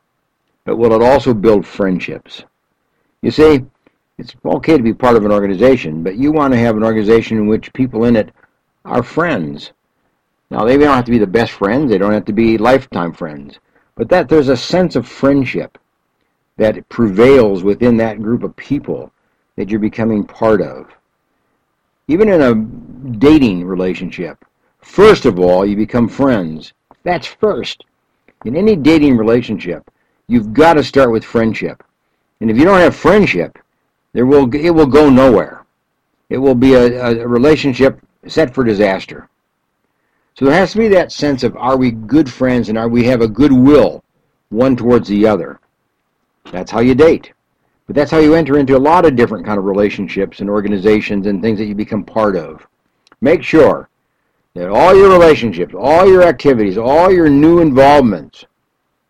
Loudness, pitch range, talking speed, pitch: -12 LUFS, 105-140 Hz, 175 wpm, 120 Hz